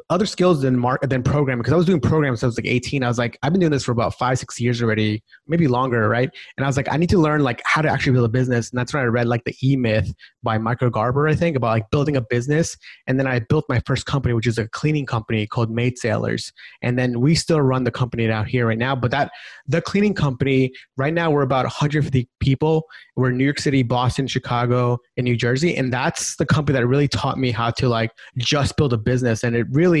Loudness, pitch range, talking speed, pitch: -20 LUFS, 120-145 Hz, 265 wpm, 130 Hz